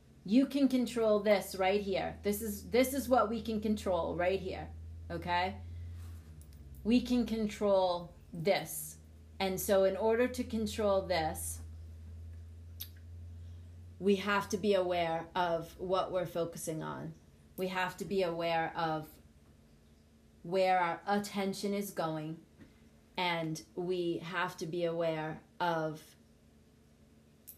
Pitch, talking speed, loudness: 170 Hz, 120 wpm, -34 LUFS